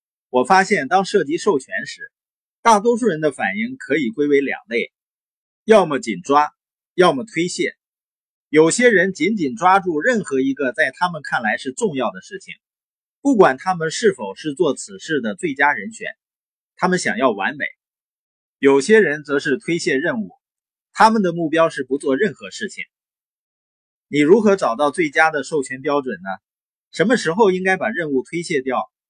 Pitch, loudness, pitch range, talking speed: 170 Hz, -18 LUFS, 140-215 Hz, 245 characters per minute